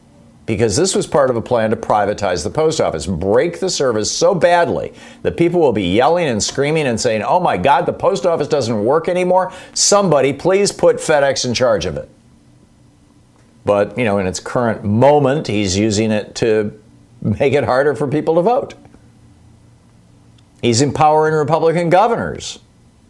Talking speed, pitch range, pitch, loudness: 170 wpm, 110-170 Hz, 140 Hz, -15 LUFS